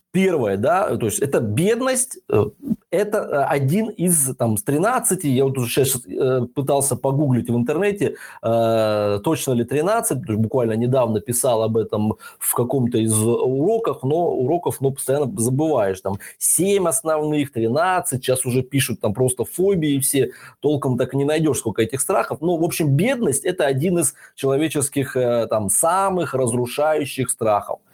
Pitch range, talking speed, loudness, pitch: 120-165 Hz, 145 wpm, -20 LUFS, 135 Hz